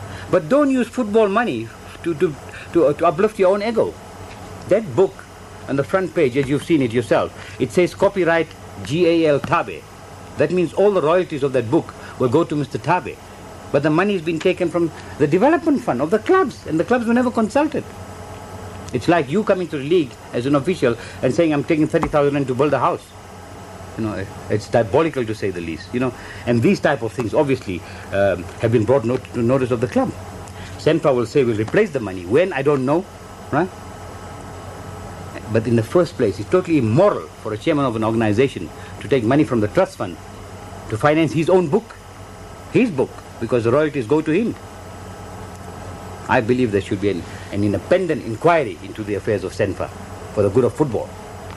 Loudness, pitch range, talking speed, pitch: -19 LUFS, 100-165 Hz, 200 wpm, 125 Hz